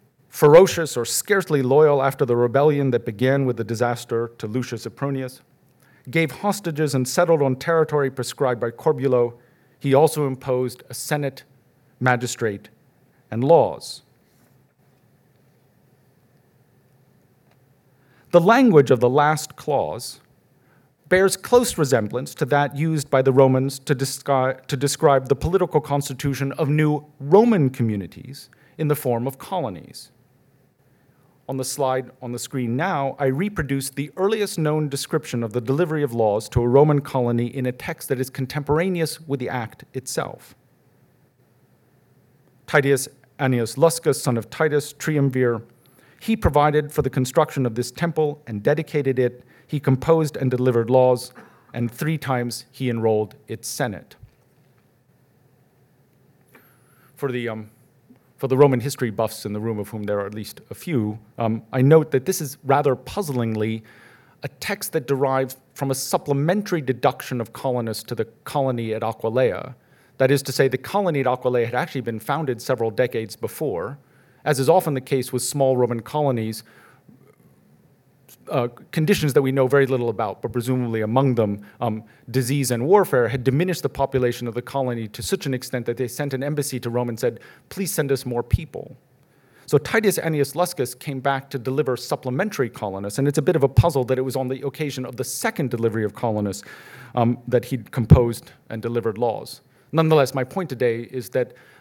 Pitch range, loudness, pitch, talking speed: 120-145 Hz, -22 LUFS, 130 Hz, 160 wpm